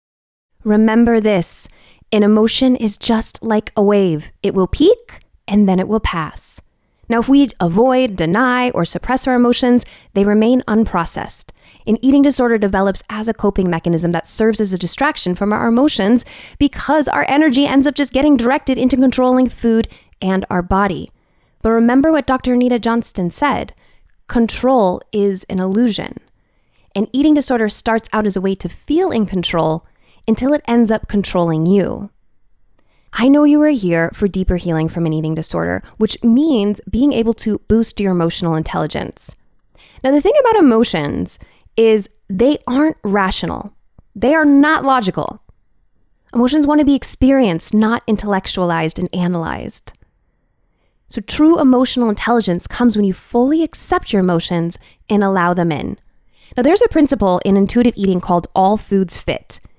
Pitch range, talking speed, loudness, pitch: 185-255 Hz, 160 wpm, -15 LUFS, 220 Hz